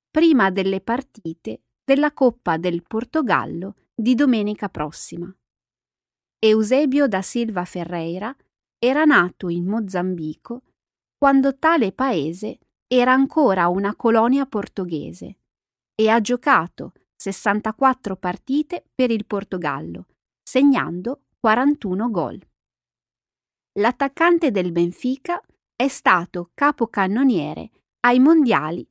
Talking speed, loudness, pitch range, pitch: 95 wpm, -20 LUFS, 185-270 Hz, 225 Hz